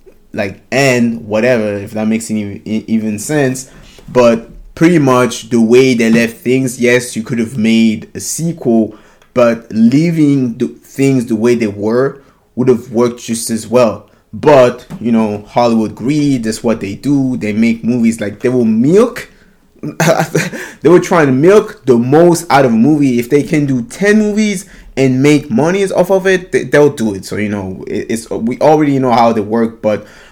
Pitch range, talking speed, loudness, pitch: 110-145 Hz, 180 wpm, -12 LUFS, 120 Hz